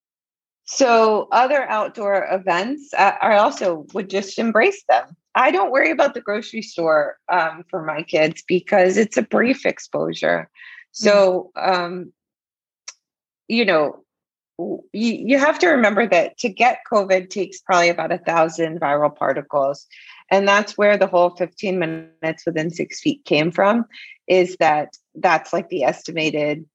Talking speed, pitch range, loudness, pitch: 145 wpm, 165-230 Hz, -19 LUFS, 190 Hz